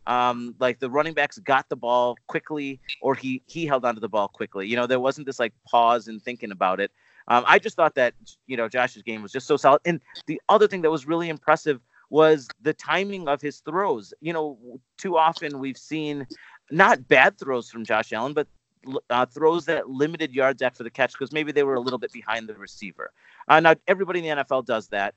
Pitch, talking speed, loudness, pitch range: 135 Hz, 225 wpm, -23 LUFS, 120-155 Hz